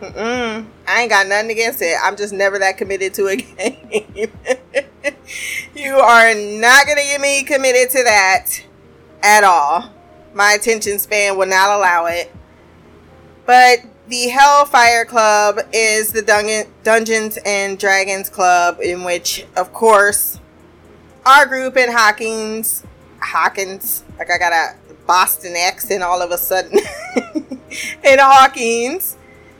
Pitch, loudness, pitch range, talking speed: 215 Hz, -13 LUFS, 190-250 Hz, 135 wpm